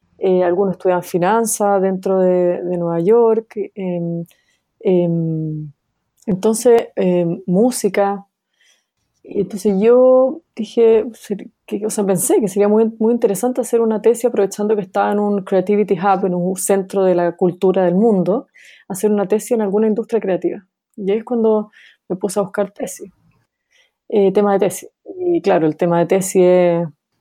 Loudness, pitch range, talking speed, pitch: -16 LUFS, 185-220 Hz, 155 wpm, 200 Hz